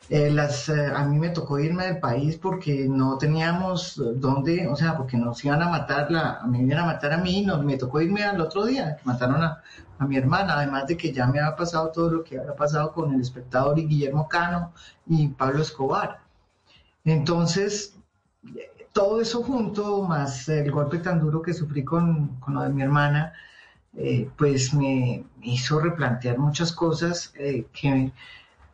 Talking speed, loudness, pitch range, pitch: 190 wpm, -24 LUFS, 135-170 Hz, 150 Hz